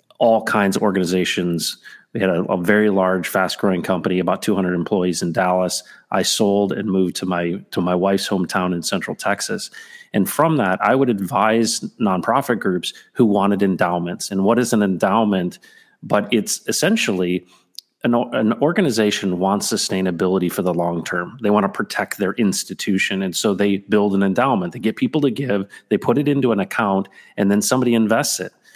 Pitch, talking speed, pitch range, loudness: 100 Hz, 180 wpm, 90-110 Hz, -19 LUFS